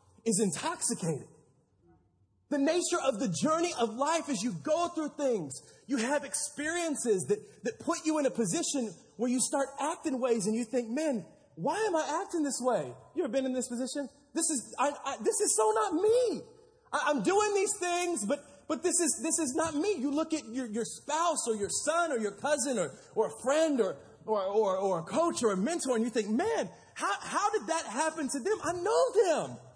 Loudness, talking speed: -31 LUFS, 210 wpm